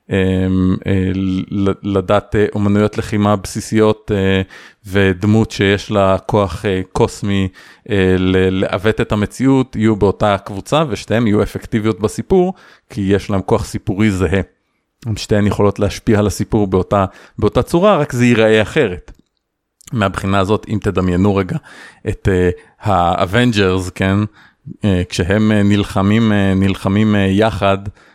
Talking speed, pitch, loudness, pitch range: 125 wpm, 100 Hz, -15 LUFS, 95-110 Hz